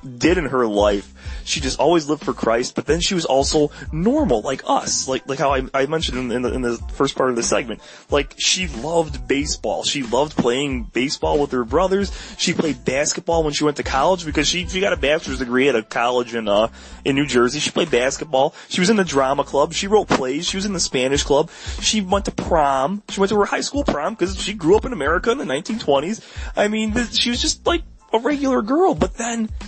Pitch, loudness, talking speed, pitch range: 165 Hz, -20 LUFS, 240 wpm, 135-210 Hz